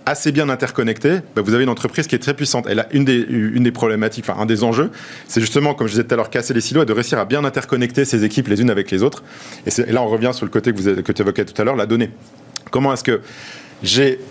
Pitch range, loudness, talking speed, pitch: 110-135 Hz, -18 LUFS, 285 wpm, 120 Hz